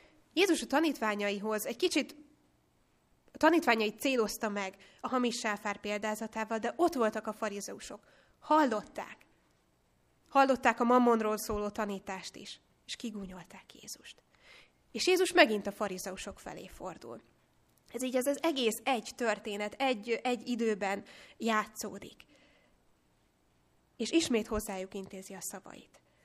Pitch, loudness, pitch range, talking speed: 220 Hz, -32 LUFS, 210-255 Hz, 120 wpm